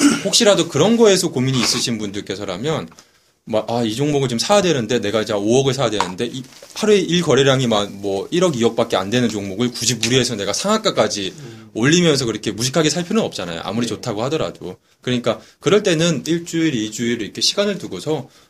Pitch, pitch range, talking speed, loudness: 130 Hz, 115-170 Hz, 420 characters per minute, -18 LUFS